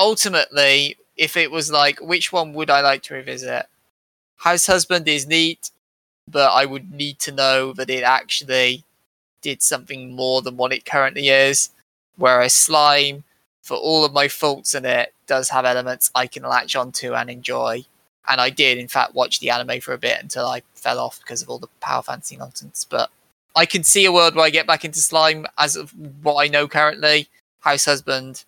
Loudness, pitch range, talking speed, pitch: -18 LUFS, 130-160 Hz, 195 wpm, 145 Hz